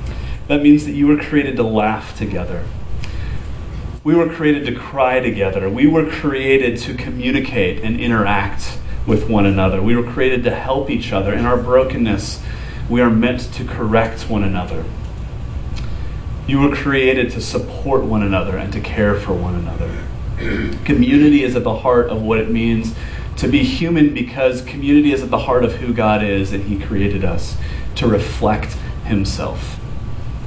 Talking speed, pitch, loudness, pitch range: 165 wpm, 115 Hz, -17 LUFS, 100-130 Hz